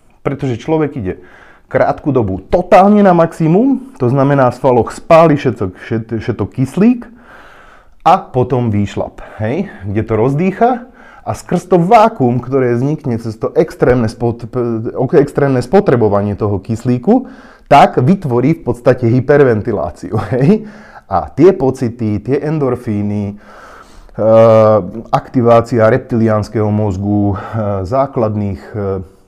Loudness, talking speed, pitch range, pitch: -13 LUFS, 105 wpm, 110-155 Hz, 125 Hz